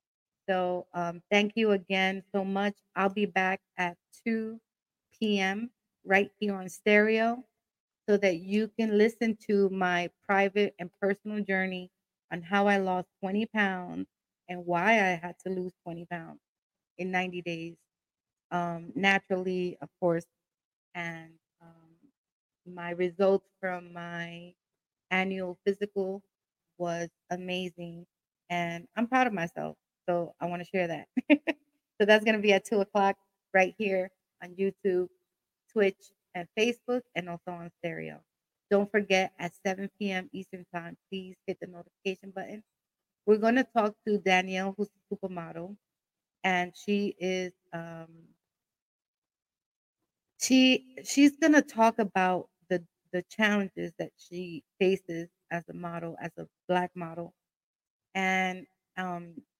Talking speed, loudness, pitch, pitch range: 135 wpm, -29 LUFS, 185 Hz, 175-205 Hz